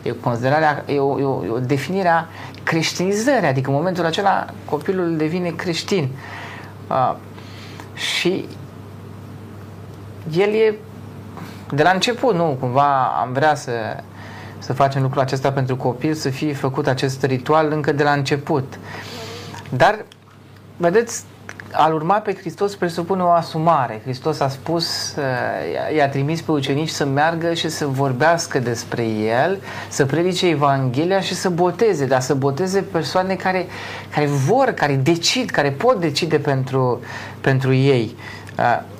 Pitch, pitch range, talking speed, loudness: 140 Hz, 120-165 Hz, 135 wpm, -19 LUFS